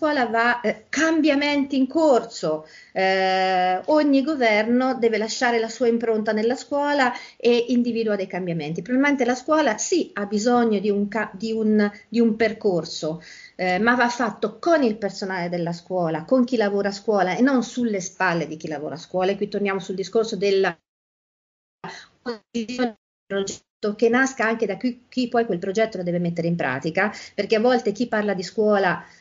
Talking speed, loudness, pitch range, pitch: 170 wpm, -22 LUFS, 190-245 Hz, 220 Hz